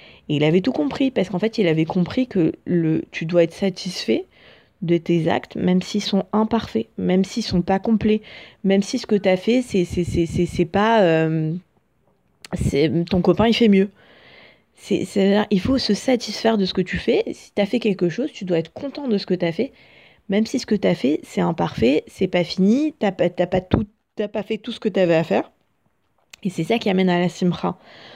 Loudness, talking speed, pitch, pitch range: -21 LUFS, 235 wpm, 195 Hz, 175-220 Hz